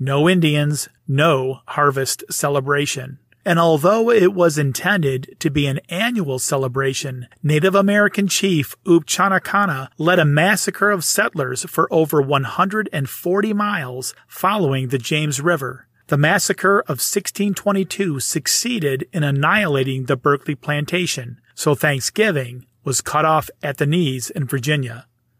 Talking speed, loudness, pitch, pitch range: 135 wpm, -18 LUFS, 150 Hz, 135-185 Hz